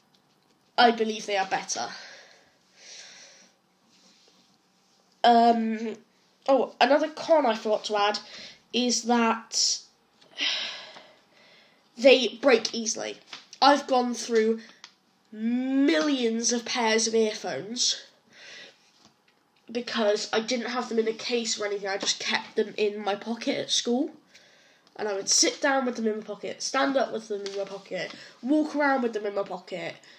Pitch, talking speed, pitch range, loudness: 230 Hz, 135 wpm, 210-250 Hz, -26 LUFS